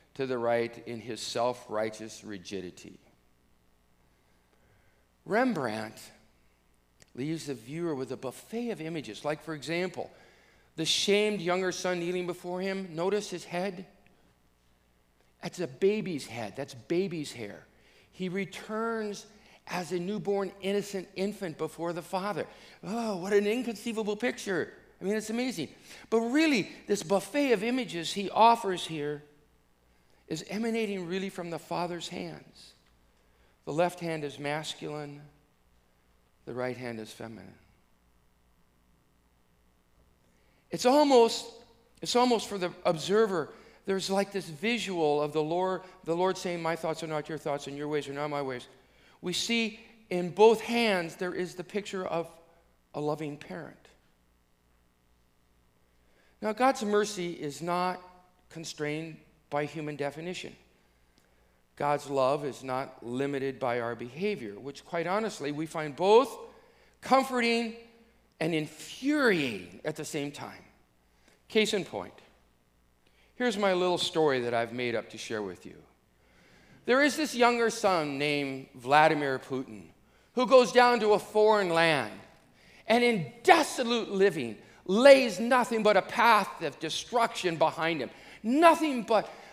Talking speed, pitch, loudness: 135 wpm, 165 Hz, -29 LUFS